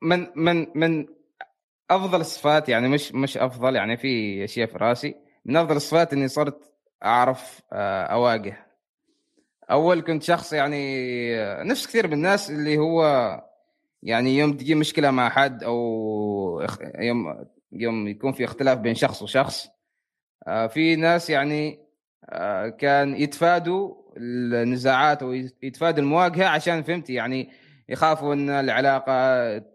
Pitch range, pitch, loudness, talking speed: 125-165 Hz, 145 Hz, -23 LUFS, 120 wpm